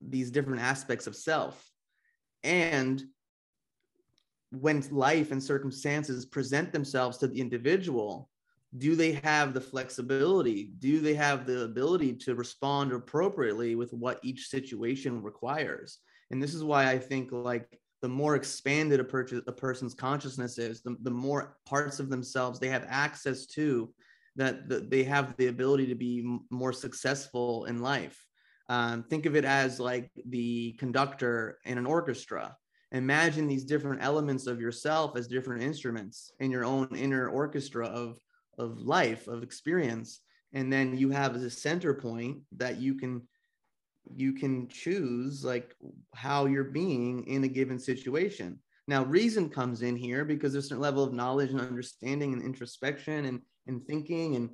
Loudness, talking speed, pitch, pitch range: -31 LUFS, 155 wpm, 130 Hz, 125-140 Hz